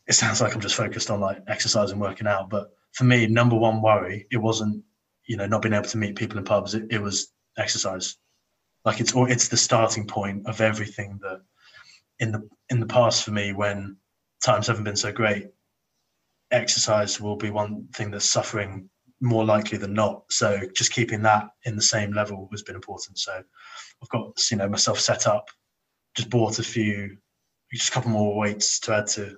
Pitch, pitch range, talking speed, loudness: 105 Hz, 105-115 Hz, 200 wpm, -23 LUFS